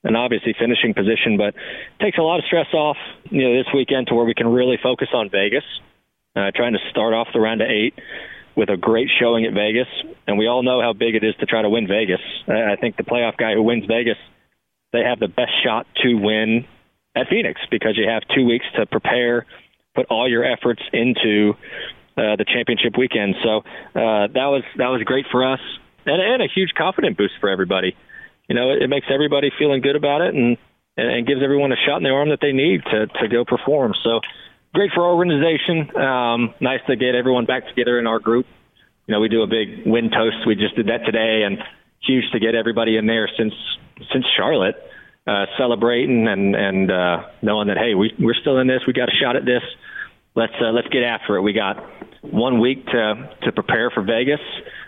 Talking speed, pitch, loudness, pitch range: 220 wpm, 120 Hz, -19 LUFS, 110-130 Hz